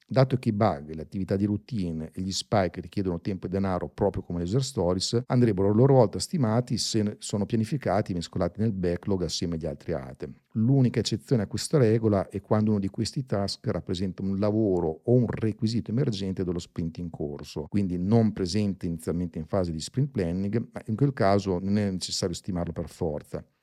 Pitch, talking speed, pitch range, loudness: 100 Hz, 195 wpm, 90-110 Hz, -27 LUFS